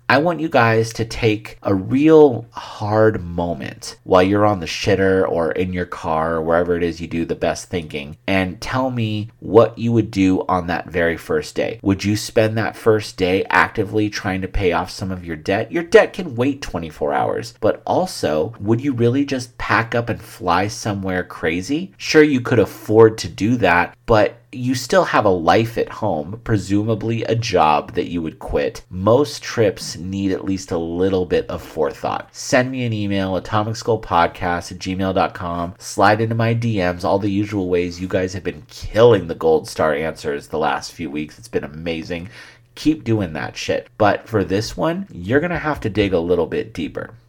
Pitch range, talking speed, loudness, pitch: 90-115 Hz, 195 wpm, -19 LUFS, 105 Hz